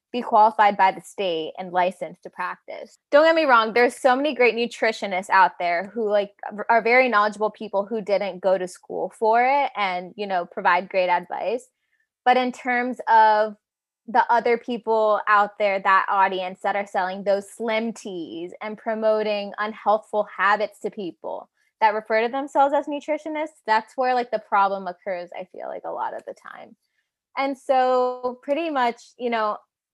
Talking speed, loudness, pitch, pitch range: 175 wpm, -22 LUFS, 220 Hz, 200-250 Hz